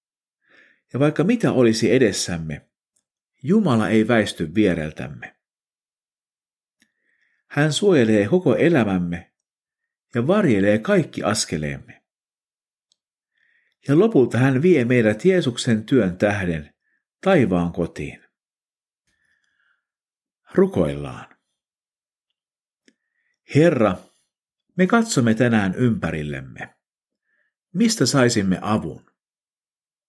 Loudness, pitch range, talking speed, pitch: -19 LUFS, 90-155 Hz, 70 wpm, 115 Hz